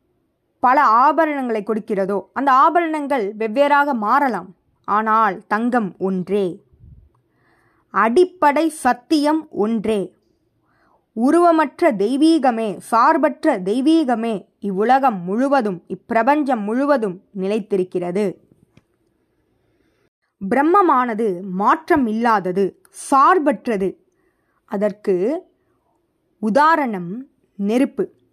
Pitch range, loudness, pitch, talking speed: 205-305 Hz, -18 LUFS, 240 Hz, 60 wpm